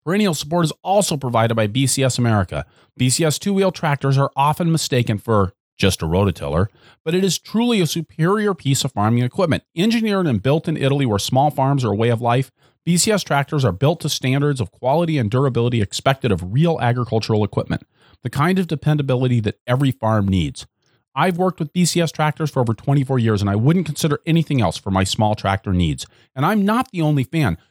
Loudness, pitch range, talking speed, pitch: -19 LUFS, 115-165 Hz, 195 wpm, 135 Hz